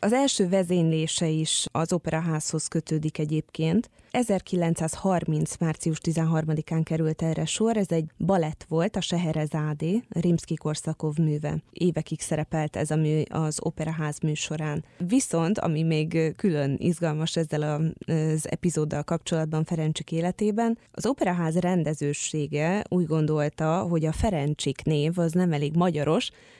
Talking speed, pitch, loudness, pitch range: 125 wpm, 160 Hz, -26 LUFS, 155-175 Hz